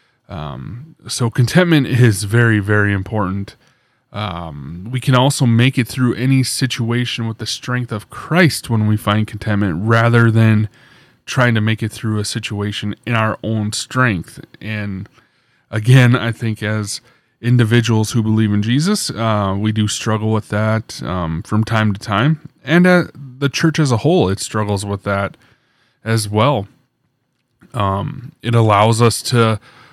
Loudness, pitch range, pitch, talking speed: -16 LUFS, 105-130 Hz, 115 Hz, 155 wpm